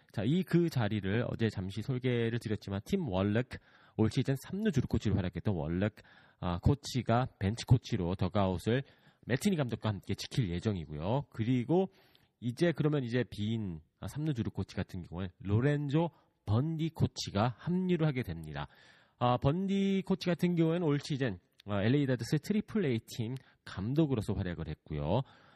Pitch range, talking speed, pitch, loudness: 100-145 Hz, 320 characters per minute, 120 Hz, -33 LUFS